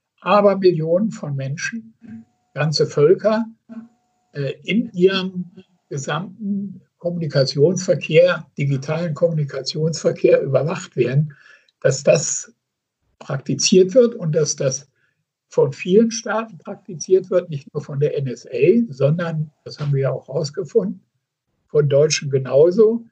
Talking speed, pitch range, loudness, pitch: 105 wpm, 145-200 Hz, -19 LUFS, 170 Hz